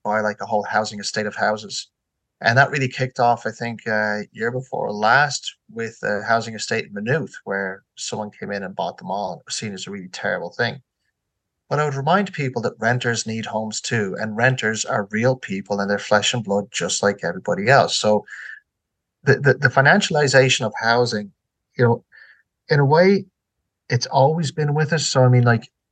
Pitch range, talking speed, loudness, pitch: 105-135 Hz, 205 wpm, -20 LUFS, 115 Hz